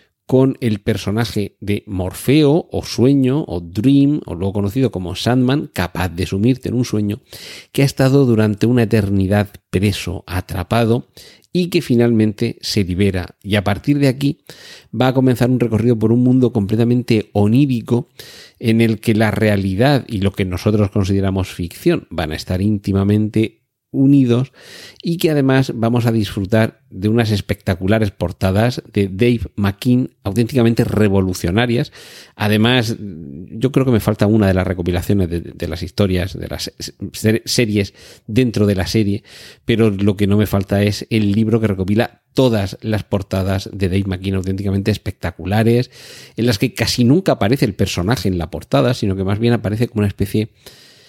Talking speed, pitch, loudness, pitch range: 165 wpm, 110 Hz, -17 LUFS, 100-120 Hz